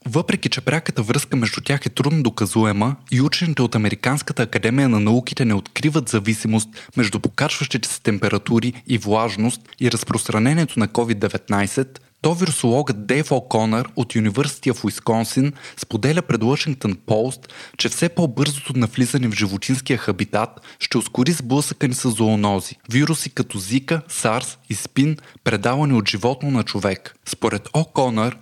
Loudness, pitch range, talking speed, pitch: -20 LUFS, 110-140 Hz, 140 wpm, 125 Hz